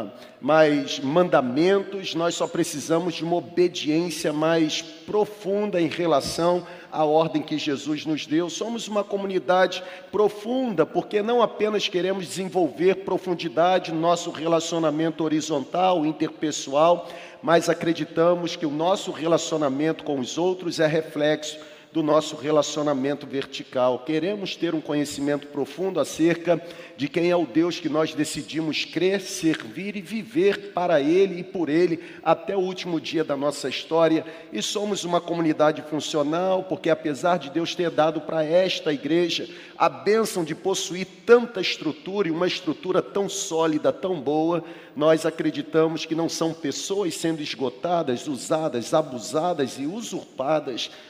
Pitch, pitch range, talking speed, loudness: 165 Hz, 155-185 Hz, 135 wpm, -24 LUFS